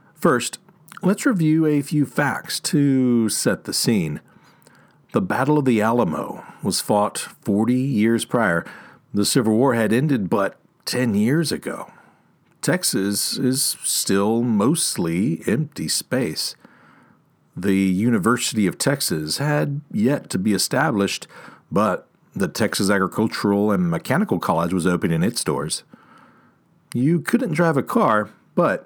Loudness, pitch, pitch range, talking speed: -21 LUFS, 120 Hz, 100-145 Hz, 130 wpm